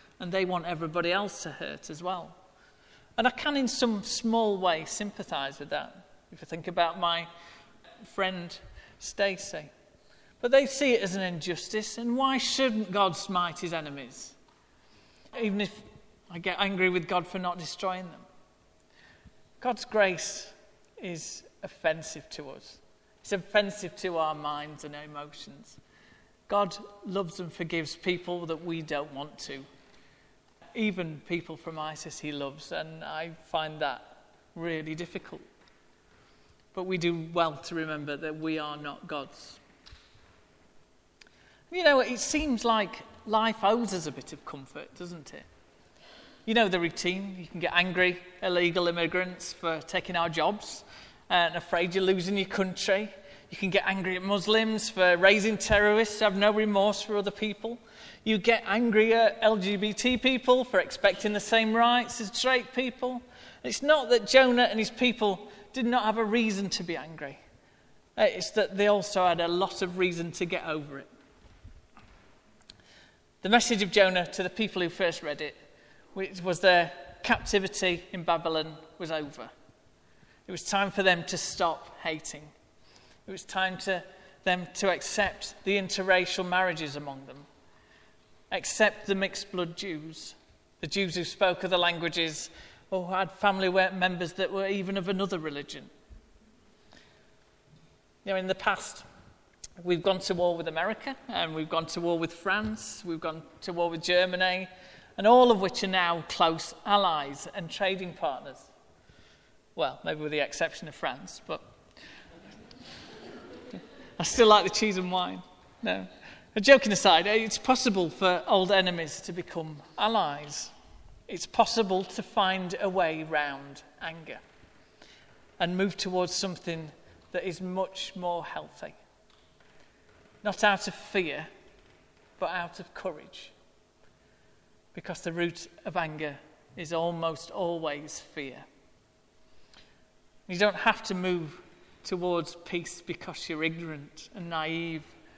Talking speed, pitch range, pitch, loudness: 145 wpm, 170-205 Hz, 185 Hz, -28 LUFS